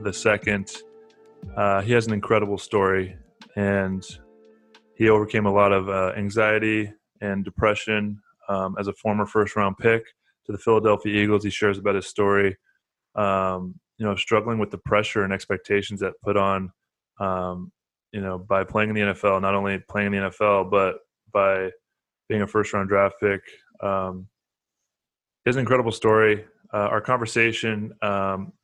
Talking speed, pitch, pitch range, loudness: 160 wpm, 100 Hz, 95-110 Hz, -23 LUFS